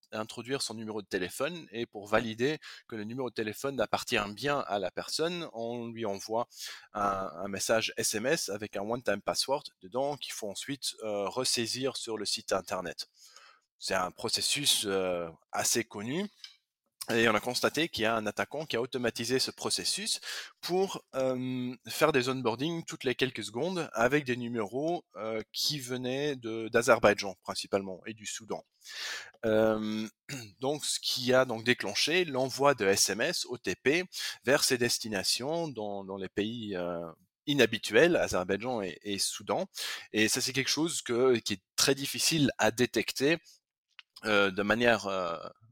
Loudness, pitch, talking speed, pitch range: -31 LUFS, 120 Hz, 155 wpm, 105-135 Hz